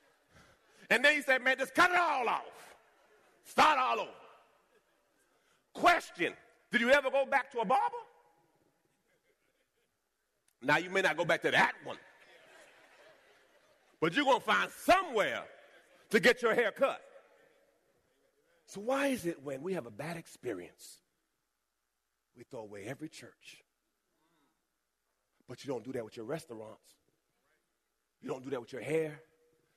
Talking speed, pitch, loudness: 145 wpm, 190 Hz, -31 LUFS